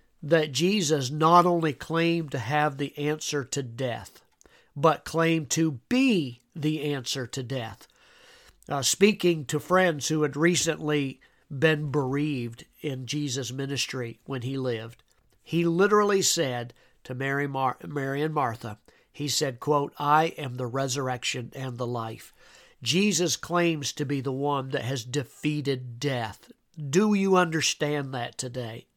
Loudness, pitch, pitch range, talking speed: -26 LUFS, 145 Hz, 130-160 Hz, 140 wpm